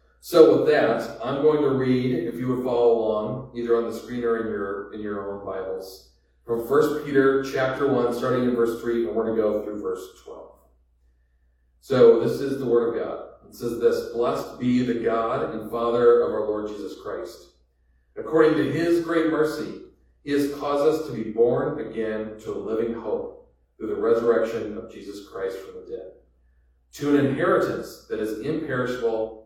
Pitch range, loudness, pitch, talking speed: 110-150 Hz, -23 LUFS, 120 Hz, 190 wpm